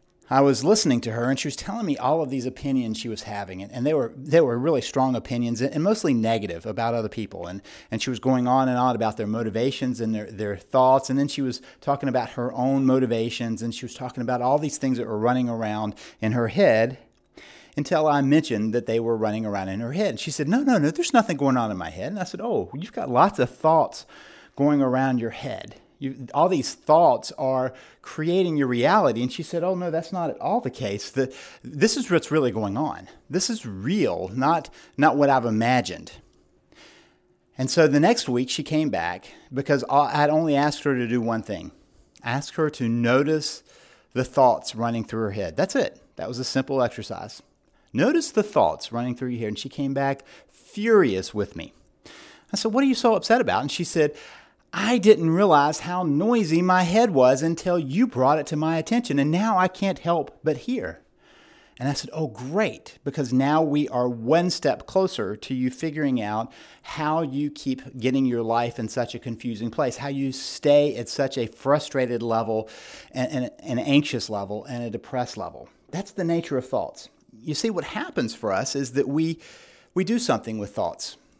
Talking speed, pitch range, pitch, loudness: 210 wpm, 120-155 Hz, 135 Hz, -24 LUFS